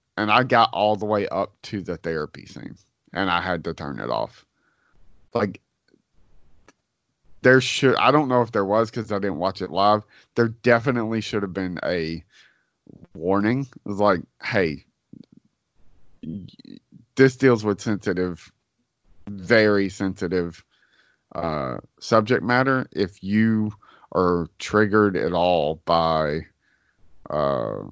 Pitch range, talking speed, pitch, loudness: 90-115 Hz, 130 wpm, 100 Hz, -22 LUFS